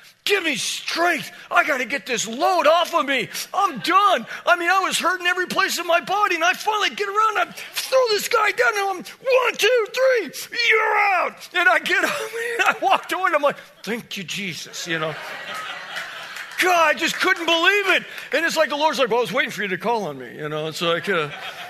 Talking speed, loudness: 240 wpm, -20 LUFS